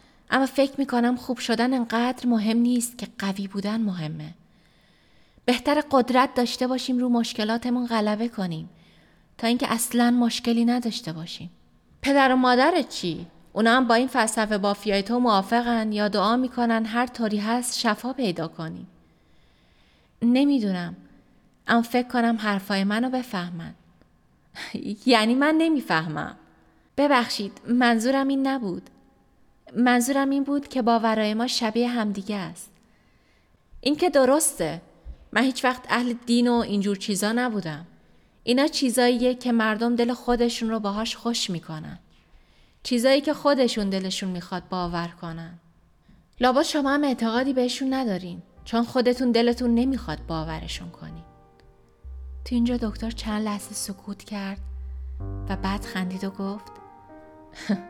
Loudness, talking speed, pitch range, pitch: -24 LUFS, 130 wpm, 195-250 Hz, 230 Hz